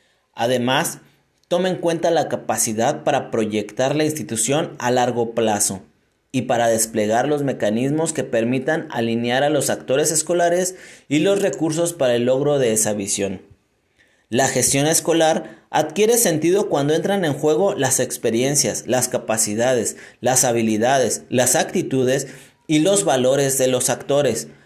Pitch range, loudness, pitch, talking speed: 115-155 Hz, -19 LUFS, 130 Hz, 140 wpm